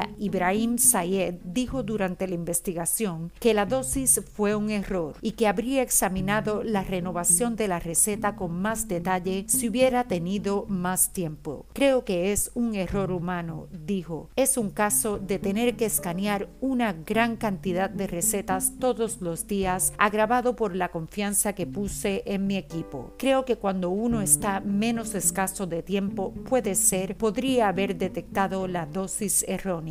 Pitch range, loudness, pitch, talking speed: 185-220 Hz, -25 LUFS, 200 Hz, 155 wpm